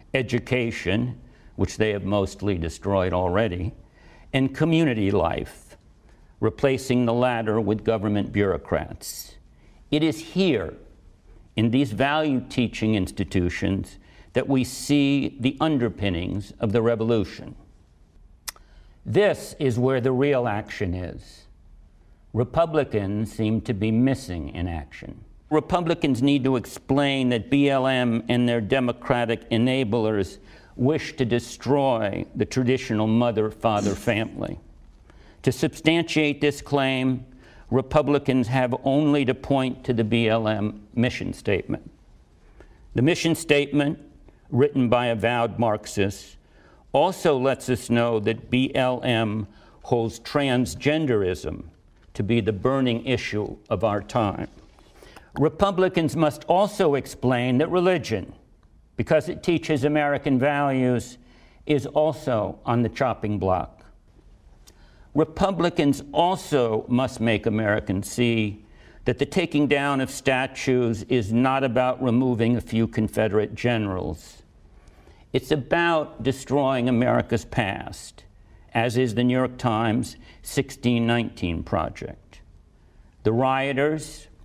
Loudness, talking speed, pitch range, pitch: -24 LUFS, 110 wpm, 105-135 Hz, 120 Hz